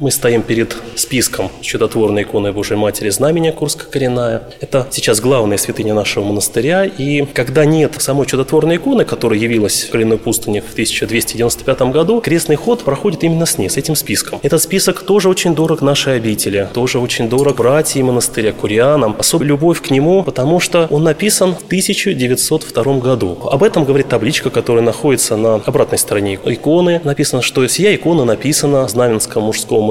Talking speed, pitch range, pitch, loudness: 165 wpm, 115-160 Hz, 135 Hz, -13 LUFS